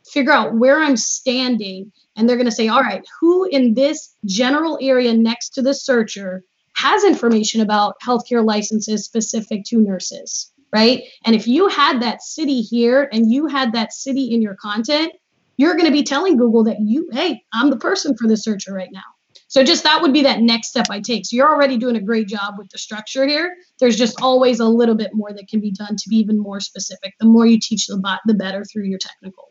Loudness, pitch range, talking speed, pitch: -17 LUFS, 215-275 Hz, 225 wpm, 235 Hz